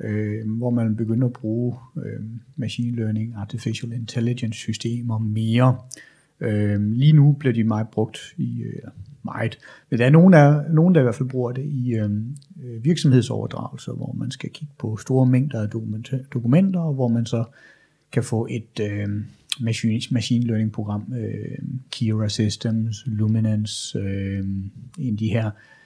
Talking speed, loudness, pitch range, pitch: 155 wpm, -22 LUFS, 110-130 Hz, 115 Hz